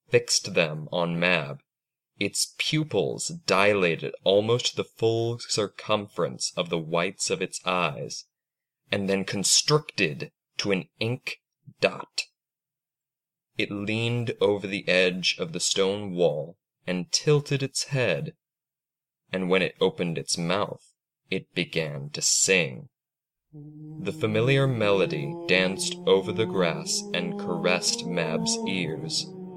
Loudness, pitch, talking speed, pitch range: -25 LUFS, 130 Hz, 120 wpm, 95-160 Hz